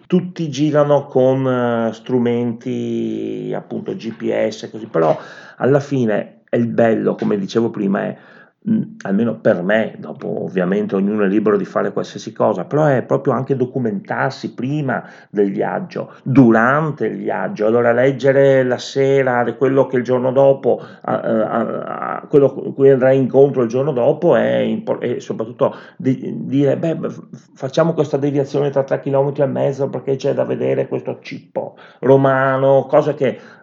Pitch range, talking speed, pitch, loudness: 120-140 Hz, 140 wpm, 130 Hz, -17 LUFS